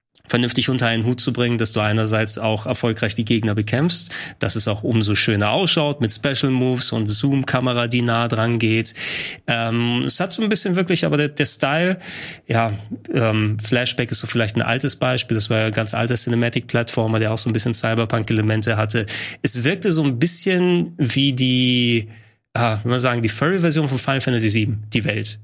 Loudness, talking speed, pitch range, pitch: -19 LUFS, 190 wpm, 110-135 Hz, 120 Hz